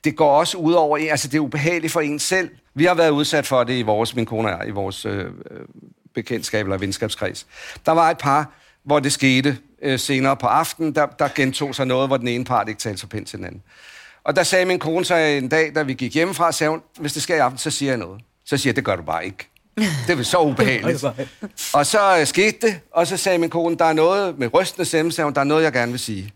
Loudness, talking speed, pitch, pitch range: -19 LUFS, 265 wpm, 145 Hz, 125-165 Hz